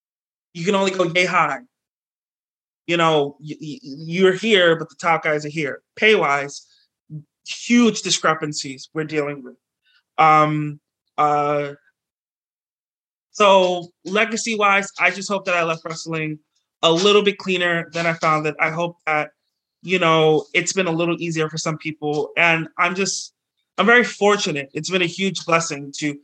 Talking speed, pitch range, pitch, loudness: 155 wpm, 150-185 Hz, 165 Hz, -19 LUFS